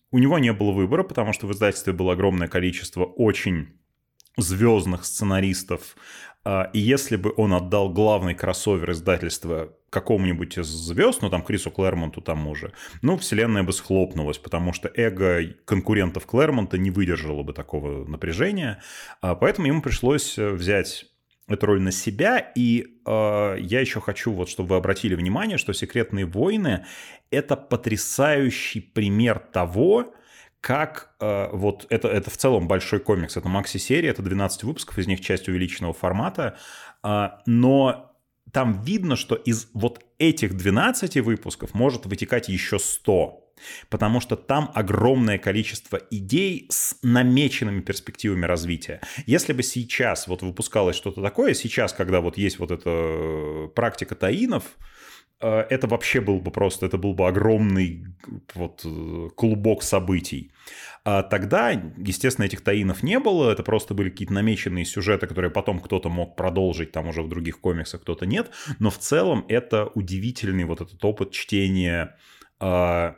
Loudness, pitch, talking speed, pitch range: -23 LUFS, 100 Hz, 145 wpm, 90-115 Hz